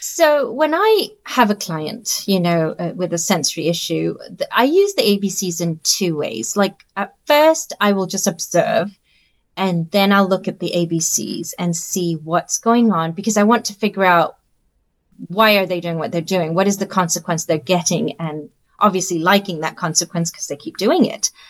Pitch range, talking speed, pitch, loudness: 170-205 Hz, 195 wpm, 185 Hz, -18 LUFS